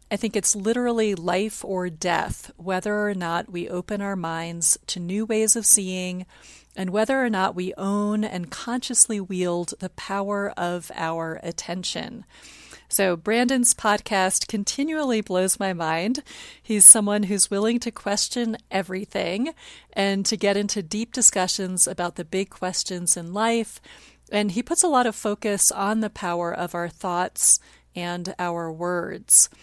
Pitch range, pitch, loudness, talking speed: 180-215 Hz, 195 Hz, -21 LUFS, 150 wpm